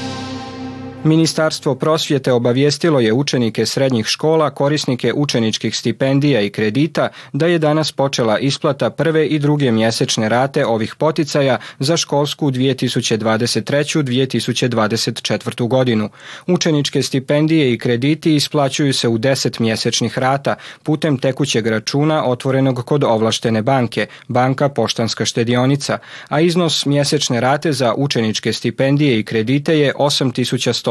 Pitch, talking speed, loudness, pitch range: 135 Hz, 115 wpm, -16 LUFS, 120-145 Hz